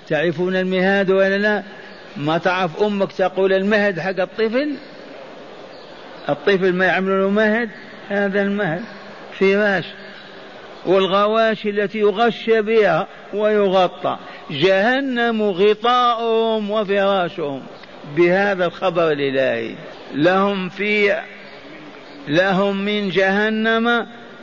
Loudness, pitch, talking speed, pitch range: -18 LUFS, 200 Hz, 85 wpm, 185-215 Hz